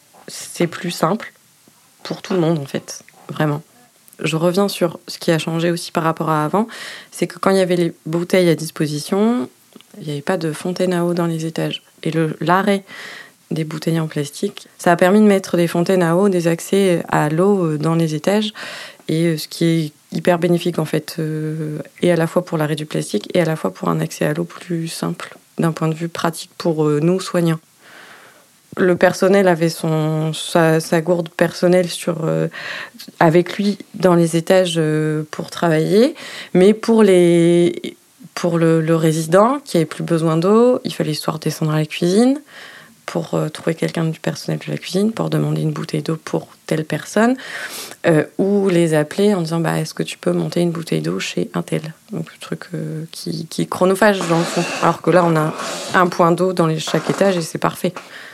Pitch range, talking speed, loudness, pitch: 160-185 Hz, 205 wpm, -18 LUFS, 170 Hz